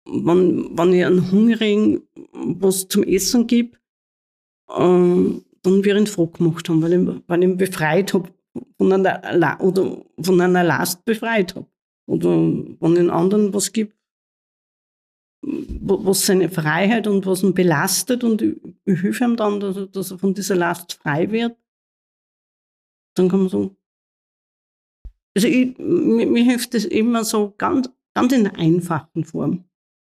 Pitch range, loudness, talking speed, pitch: 175-220 Hz, -19 LUFS, 150 wpm, 190 Hz